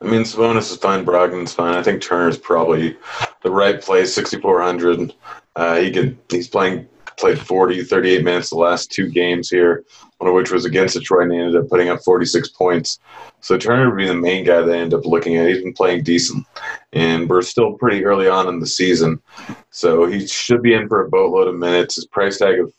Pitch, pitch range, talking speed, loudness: 90 Hz, 85-95 Hz, 215 wpm, -16 LUFS